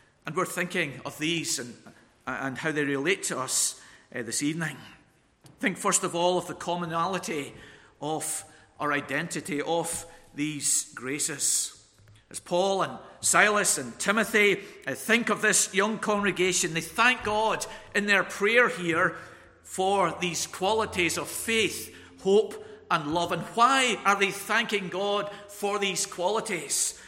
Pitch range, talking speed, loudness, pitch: 150-205 Hz, 140 wpm, -26 LUFS, 175 Hz